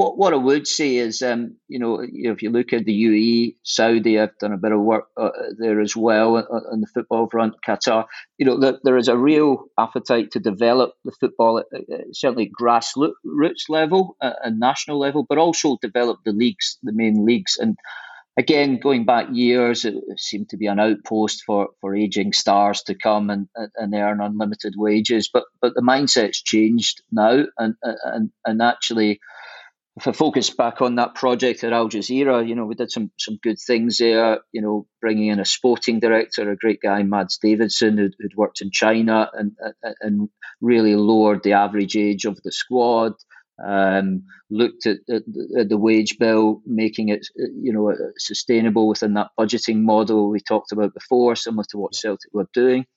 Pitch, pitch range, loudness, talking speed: 110 Hz, 105-120 Hz, -20 LUFS, 185 wpm